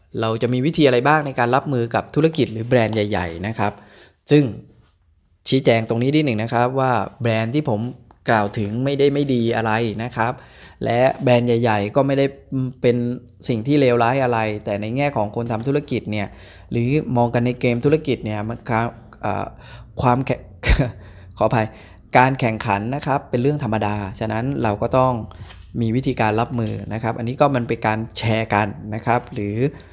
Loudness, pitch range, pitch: -20 LUFS, 110-130 Hz, 115 Hz